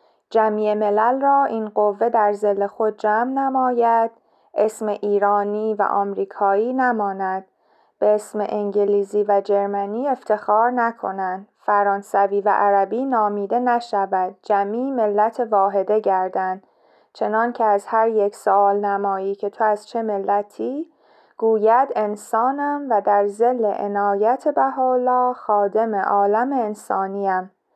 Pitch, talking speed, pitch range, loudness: 210 Hz, 115 wpm, 200-230 Hz, -20 LUFS